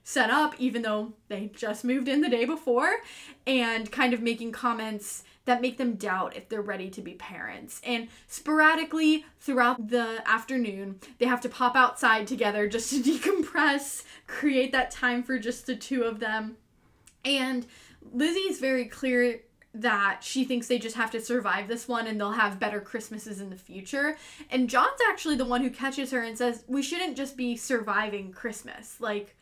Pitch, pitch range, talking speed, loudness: 245 Hz, 225-265 Hz, 180 wpm, -27 LUFS